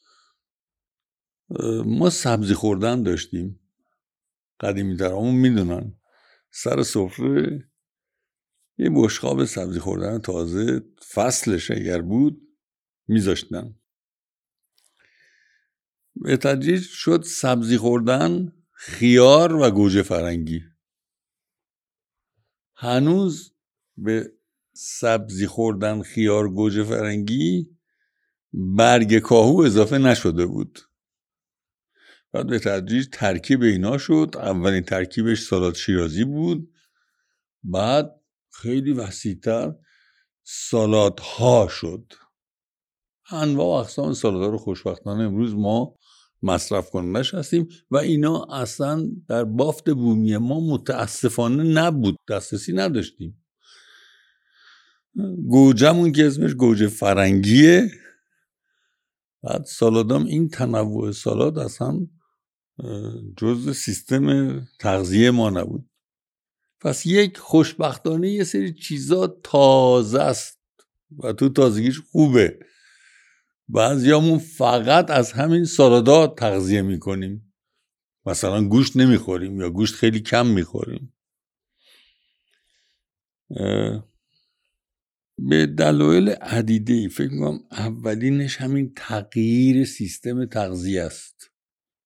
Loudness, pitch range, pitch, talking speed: -20 LUFS, 105-150 Hz, 120 Hz, 85 wpm